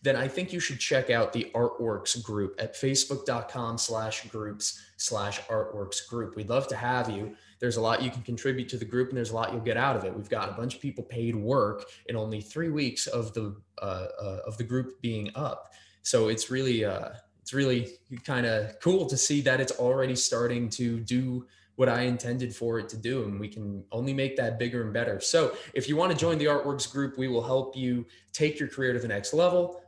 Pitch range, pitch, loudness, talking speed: 115-135 Hz, 120 Hz, -29 LUFS, 225 wpm